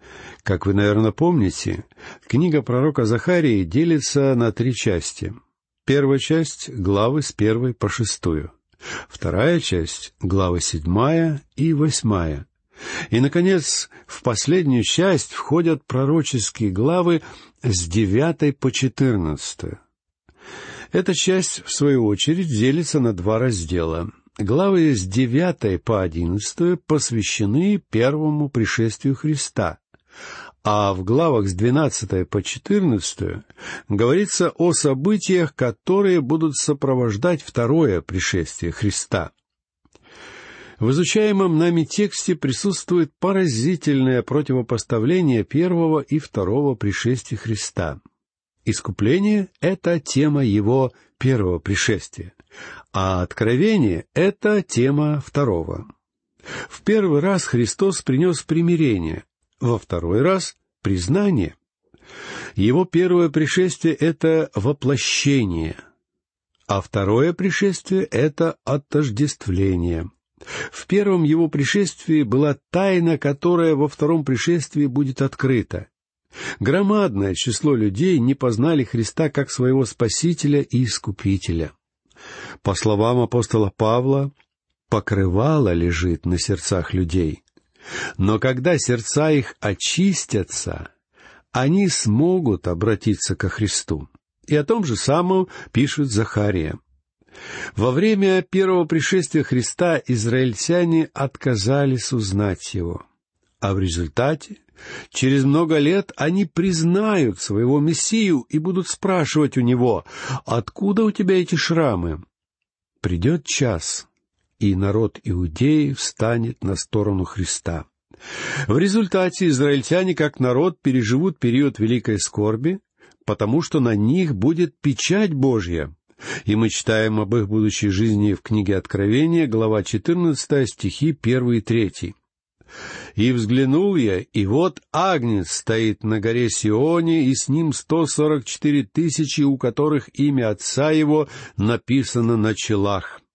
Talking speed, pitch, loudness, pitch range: 110 wpm, 130 Hz, -20 LUFS, 105-160 Hz